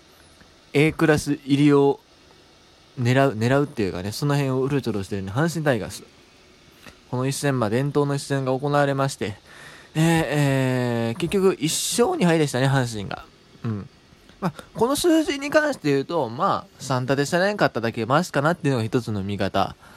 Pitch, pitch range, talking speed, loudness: 140 Hz, 115-150 Hz, 350 characters per minute, -22 LUFS